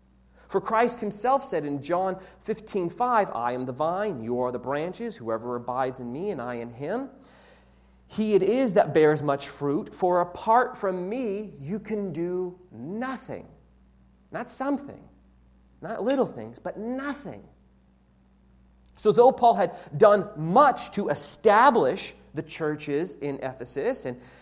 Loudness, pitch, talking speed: -26 LUFS, 170 Hz, 145 wpm